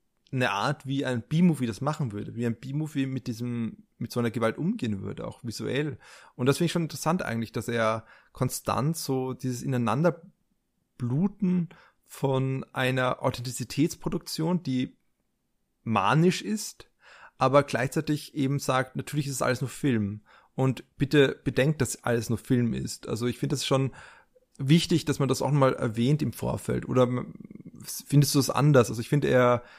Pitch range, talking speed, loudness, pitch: 120-150 Hz, 165 wpm, -27 LUFS, 130 Hz